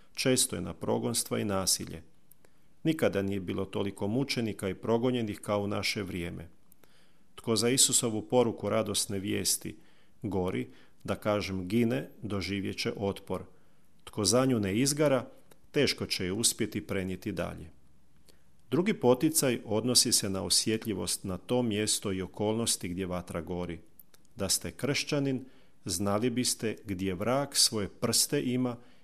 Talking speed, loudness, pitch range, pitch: 135 wpm, -30 LUFS, 95-120 Hz, 105 Hz